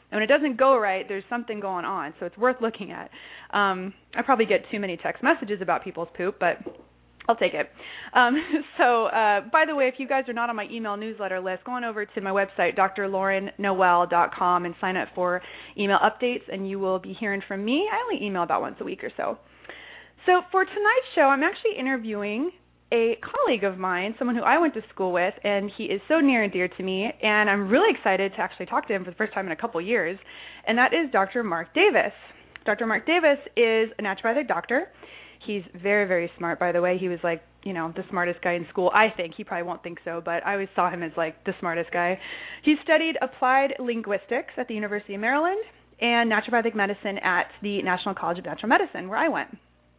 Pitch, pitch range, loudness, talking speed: 205 Hz, 185-255 Hz, -25 LUFS, 225 wpm